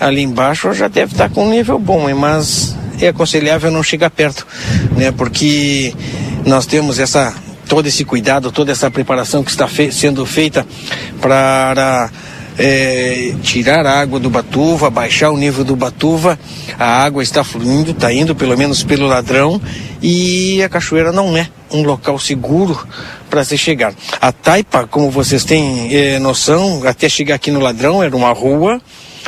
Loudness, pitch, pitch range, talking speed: -12 LUFS, 140 Hz, 130-155 Hz, 160 wpm